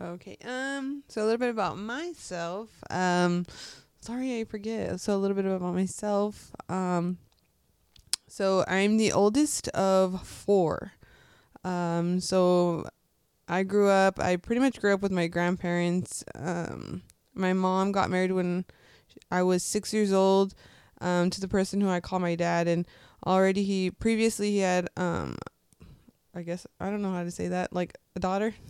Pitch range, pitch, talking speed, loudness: 180-205 Hz, 190 Hz, 160 wpm, -28 LUFS